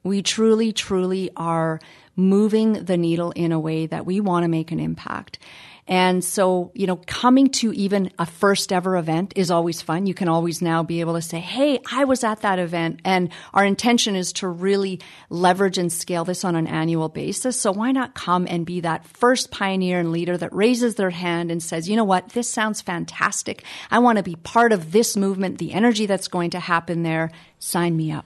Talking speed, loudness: 210 wpm, -21 LUFS